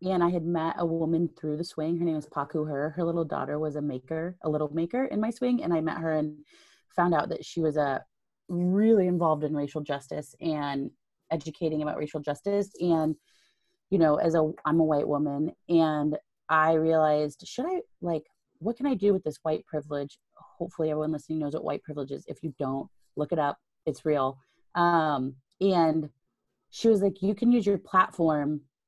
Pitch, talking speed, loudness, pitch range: 160 Hz, 200 wpm, -28 LUFS, 150-175 Hz